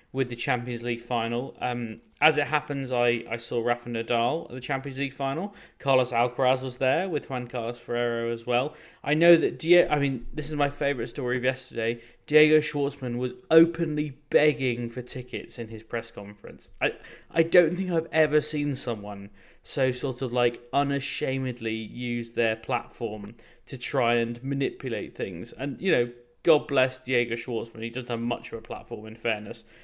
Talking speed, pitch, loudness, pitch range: 180 wpm, 125 Hz, -27 LUFS, 120-140 Hz